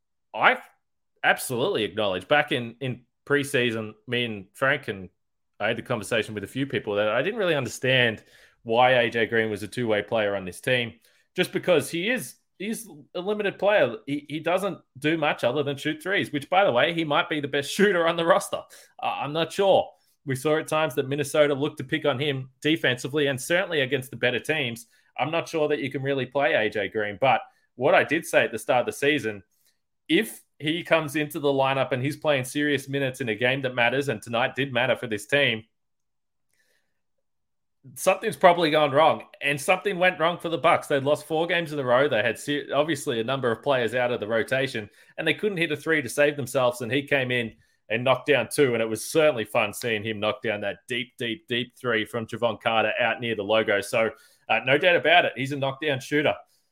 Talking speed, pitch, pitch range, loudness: 220 wpm, 140 Hz, 120-155 Hz, -24 LUFS